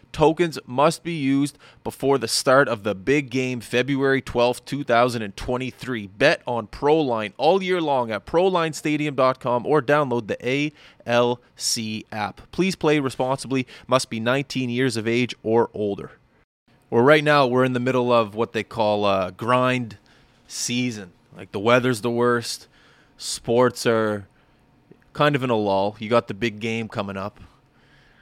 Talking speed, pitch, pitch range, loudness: 155 wpm, 125 Hz, 115-140 Hz, -22 LUFS